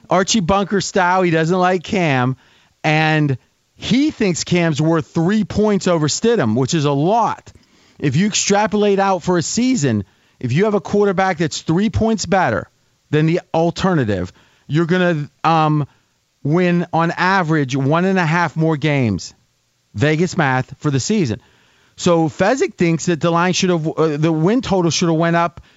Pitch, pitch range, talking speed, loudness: 170 Hz, 150-190 Hz, 170 wpm, -17 LUFS